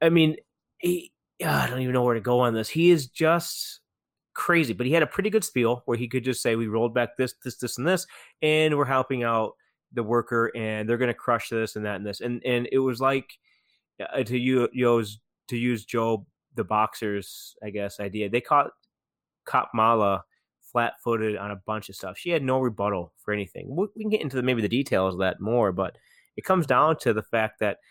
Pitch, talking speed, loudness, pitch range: 120 Hz, 230 wpm, -25 LUFS, 110-135 Hz